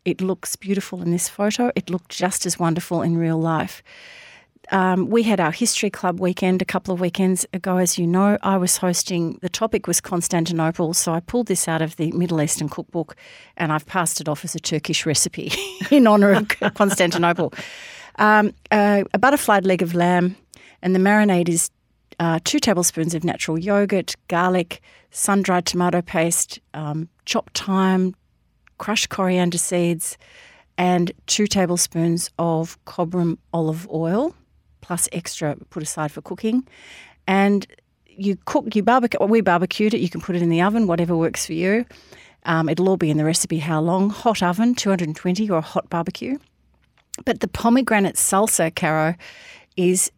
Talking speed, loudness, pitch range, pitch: 170 wpm, -20 LUFS, 170-200 Hz, 180 Hz